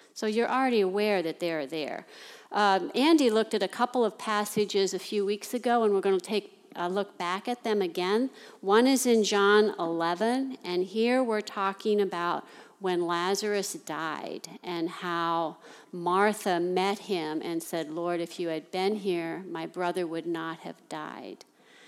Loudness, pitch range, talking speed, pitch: -28 LUFS, 175-215 Hz, 170 wpm, 195 Hz